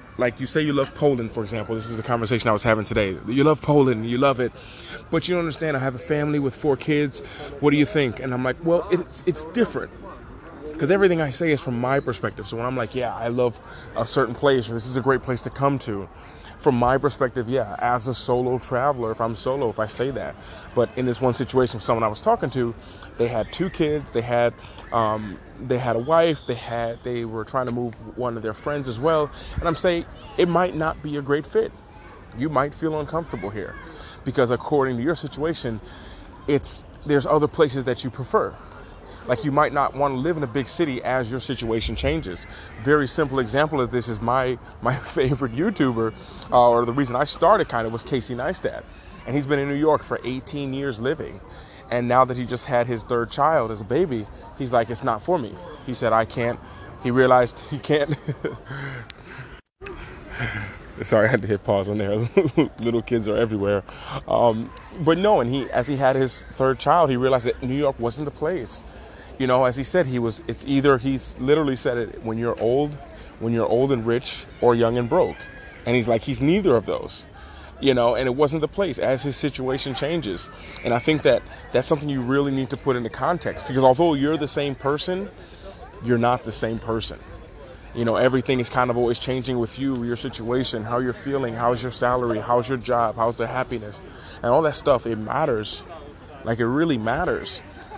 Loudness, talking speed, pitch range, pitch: -23 LUFS, 215 wpm, 115-145 Hz, 125 Hz